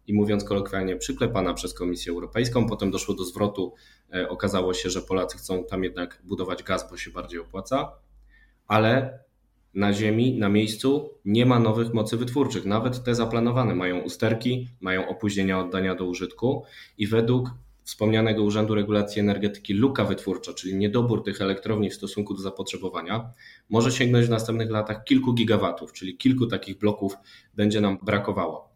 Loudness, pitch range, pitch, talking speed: -25 LUFS, 95-115 Hz, 105 Hz, 155 wpm